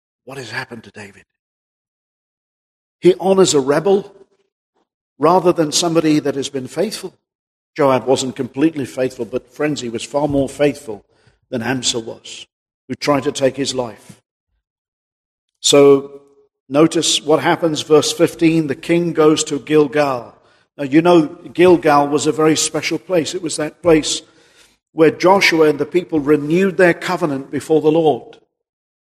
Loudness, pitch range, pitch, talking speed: -16 LUFS, 135-165 Hz, 150 Hz, 145 wpm